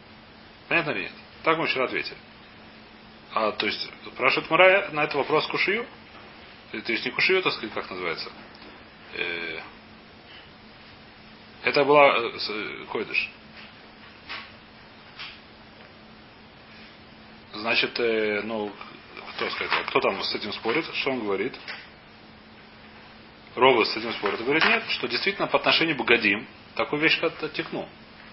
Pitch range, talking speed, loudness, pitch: 115-165 Hz, 120 wpm, -24 LUFS, 150 Hz